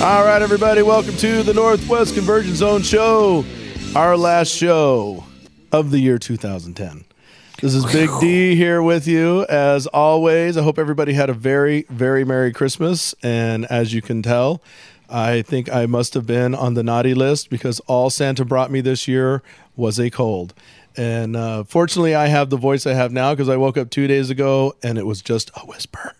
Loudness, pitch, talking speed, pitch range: -17 LUFS, 135 Hz, 190 wpm, 120-165 Hz